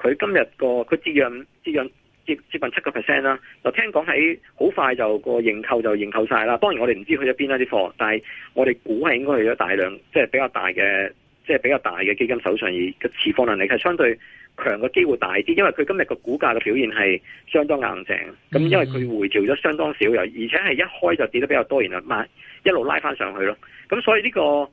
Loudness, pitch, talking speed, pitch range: -21 LUFS, 130 Hz, 360 characters per minute, 115-165 Hz